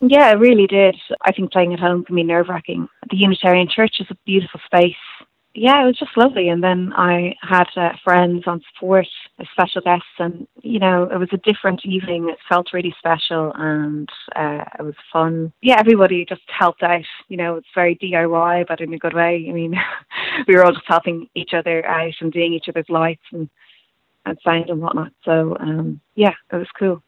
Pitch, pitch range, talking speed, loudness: 175 Hz, 165-190 Hz, 205 wpm, -17 LUFS